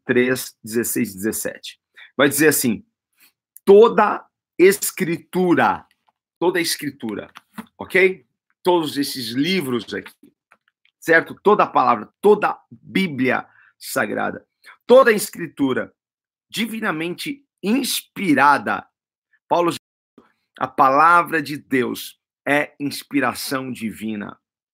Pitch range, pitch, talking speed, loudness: 125-205 Hz, 160 Hz, 80 wpm, -19 LUFS